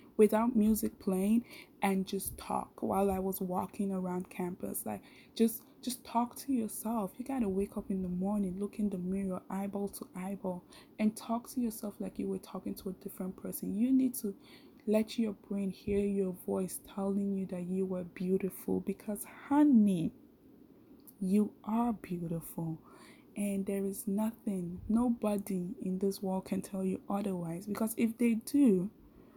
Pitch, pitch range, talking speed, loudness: 200 Hz, 190-230 Hz, 165 wpm, -34 LUFS